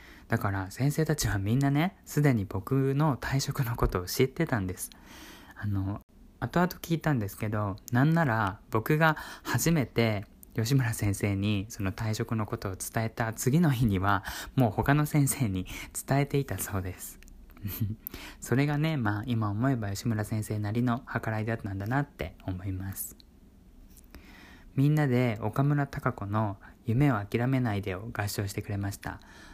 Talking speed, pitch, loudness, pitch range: 295 characters per minute, 115 Hz, -29 LUFS, 100-135 Hz